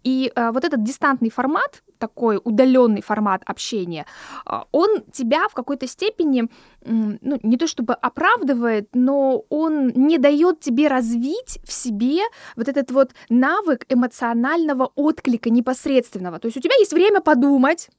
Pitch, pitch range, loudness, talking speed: 260 Hz, 235-295 Hz, -19 LUFS, 135 wpm